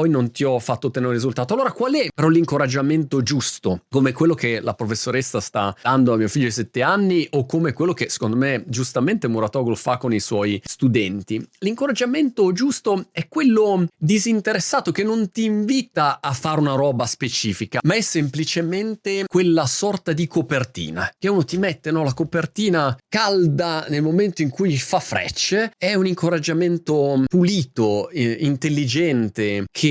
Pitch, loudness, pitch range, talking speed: 155 Hz, -20 LUFS, 125-180 Hz, 165 wpm